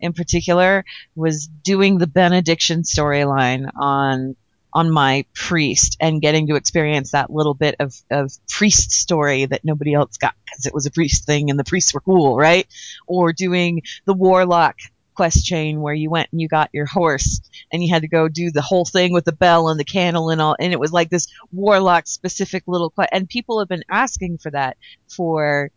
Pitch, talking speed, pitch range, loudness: 160 Hz, 200 wpm, 145-180 Hz, -17 LUFS